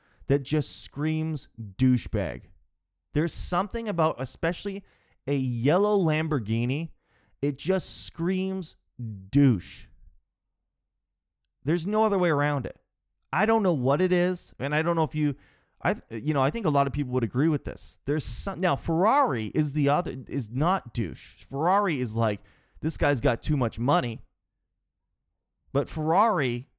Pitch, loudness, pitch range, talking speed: 145 Hz, -27 LUFS, 120-170 Hz, 150 wpm